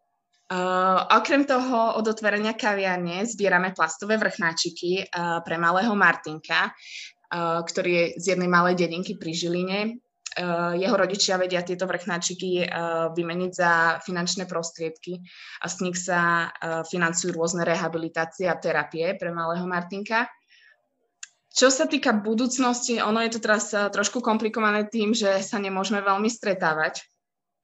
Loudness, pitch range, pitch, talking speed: -24 LUFS, 170-210 Hz, 185 Hz, 135 wpm